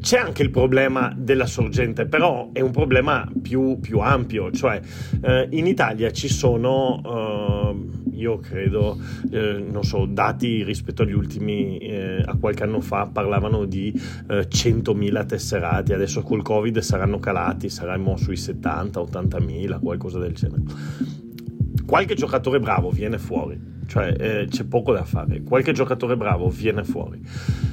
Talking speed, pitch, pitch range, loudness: 145 wpm, 120 Hz, 105-130 Hz, -22 LUFS